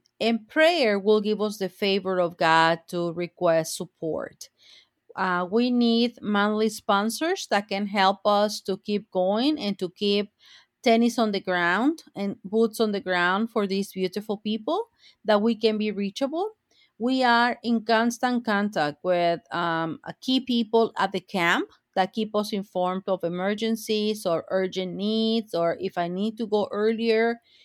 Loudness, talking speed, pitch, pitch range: -25 LUFS, 160 wpm, 210 Hz, 185-230 Hz